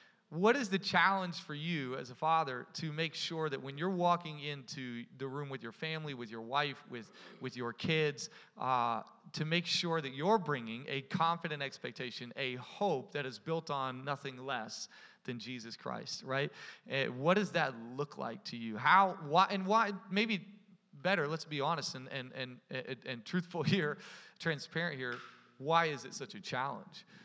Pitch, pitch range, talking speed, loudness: 150 Hz, 130-175 Hz, 180 wpm, -36 LUFS